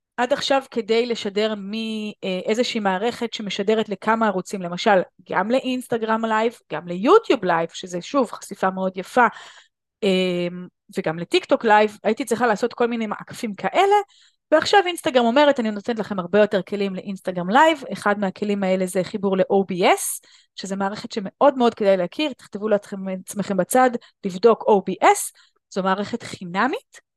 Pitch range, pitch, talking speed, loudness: 190-240 Hz, 210 Hz, 140 wpm, -21 LUFS